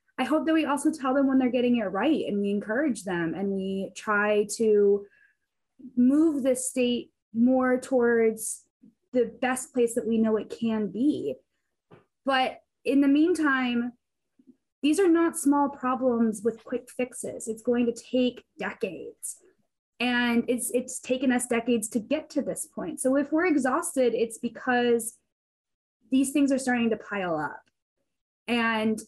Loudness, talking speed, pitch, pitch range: -26 LUFS, 155 wpm, 250 Hz, 230-275 Hz